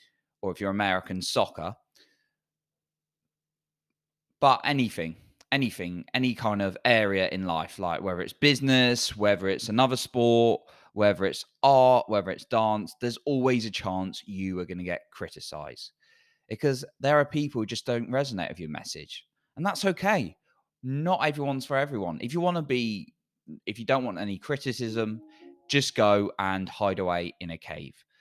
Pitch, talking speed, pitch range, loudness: 115 Hz, 160 wpm, 95-135 Hz, -27 LUFS